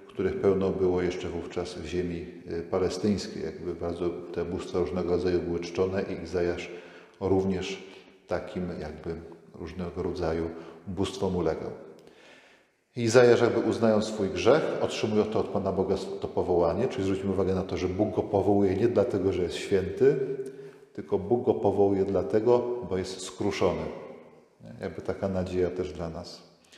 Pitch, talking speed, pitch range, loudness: 95 Hz, 145 wpm, 90-105 Hz, -28 LUFS